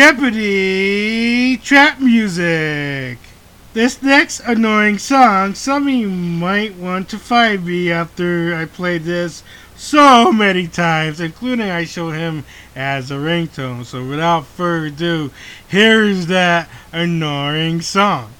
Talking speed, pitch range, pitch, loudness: 120 wpm, 160-220 Hz, 175 Hz, -15 LUFS